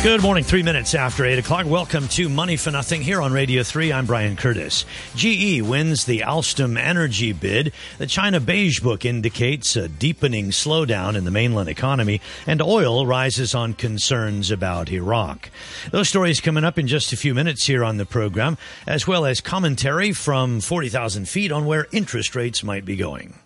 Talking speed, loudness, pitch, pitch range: 180 wpm, -20 LUFS, 130 Hz, 115-160 Hz